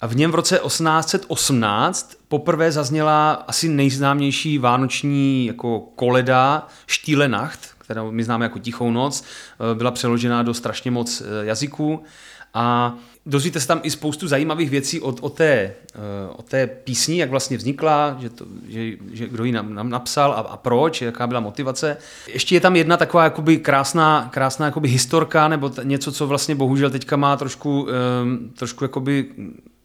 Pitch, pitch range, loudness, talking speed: 135 Hz, 120-150 Hz, -19 LUFS, 160 wpm